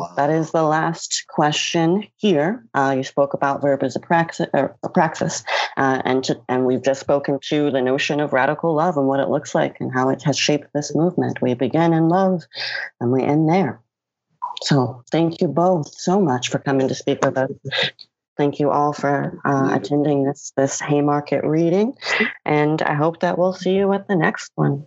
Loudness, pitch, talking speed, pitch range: -20 LUFS, 145 Hz, 200 wpm, 135-165 Hz